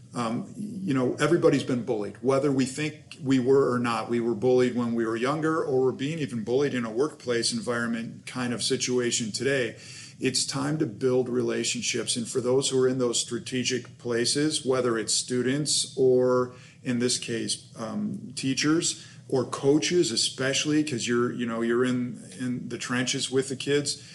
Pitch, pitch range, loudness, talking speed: 130 Hz, 120-140 Hz, -26 LUFS, 175 wpm